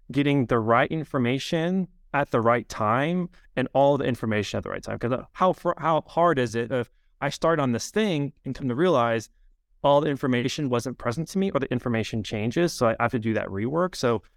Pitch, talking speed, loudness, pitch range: 130 Hz, 215 wpm, -25 LUFS, 115-160 Hz